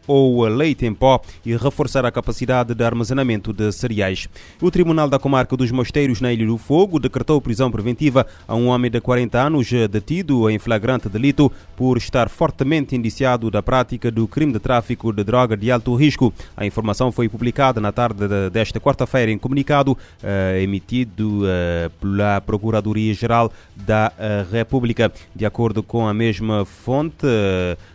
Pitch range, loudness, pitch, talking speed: 105-130 Hz, -19 LUFS, 120 Hz, 155 wpm